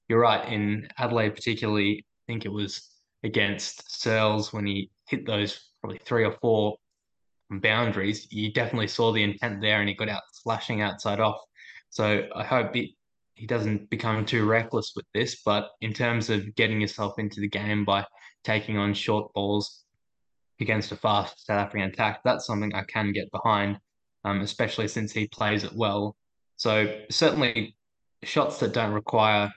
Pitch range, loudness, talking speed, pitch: 105-110 Hz, -27 LUFS, 170 wpm, 105 Hz